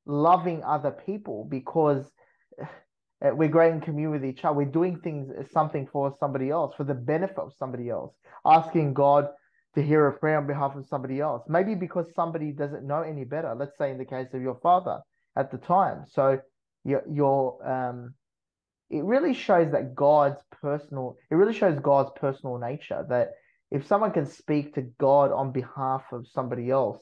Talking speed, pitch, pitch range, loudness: 180 wpm, 145 Hz, 135-160 Hz, -26 LUFS